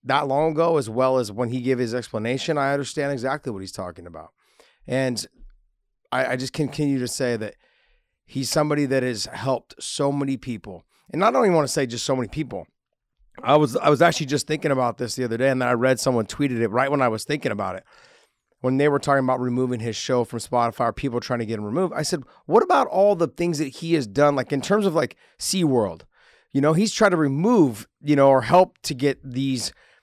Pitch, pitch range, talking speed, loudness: 135 Hz, 125-150 Hz, 235 wpm, -22 LUFS